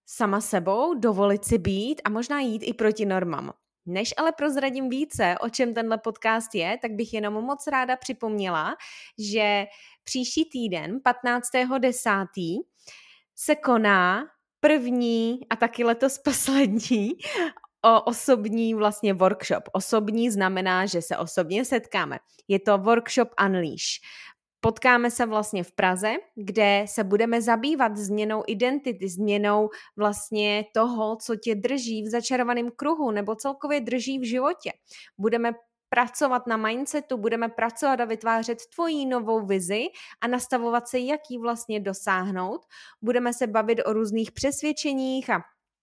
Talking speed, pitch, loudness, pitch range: 130 wpm, 230 Hz, -25 LUFS, 210-255 Hz